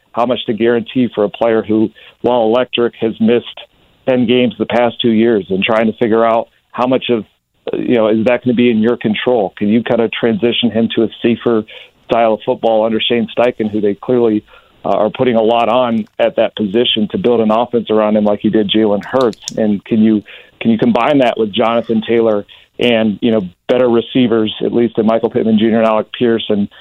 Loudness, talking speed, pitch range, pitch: -14 LUFS, 220 wpm, 110-120 Hz, 115 Hz